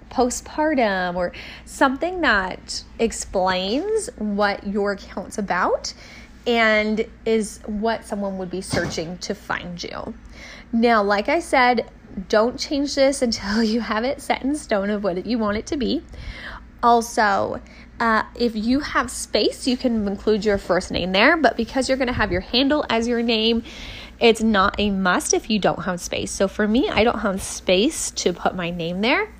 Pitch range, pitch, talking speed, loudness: 200-250 Hz, 225 Hz, 175 wpm, -21 LUFS